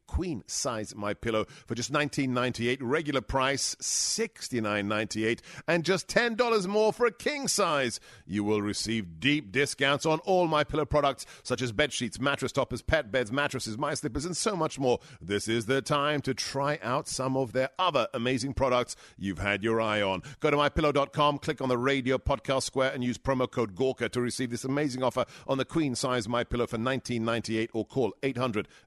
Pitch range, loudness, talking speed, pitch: 120-145 Hz, -29 LUFS, 210 wpm, 130 Hz